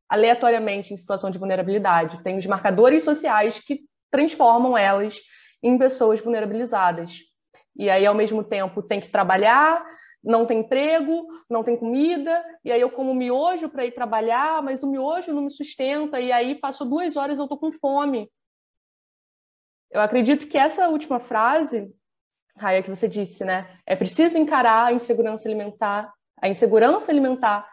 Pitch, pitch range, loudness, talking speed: 235 Hz, 210-285 Hz, -21 LUFS, 155 wpm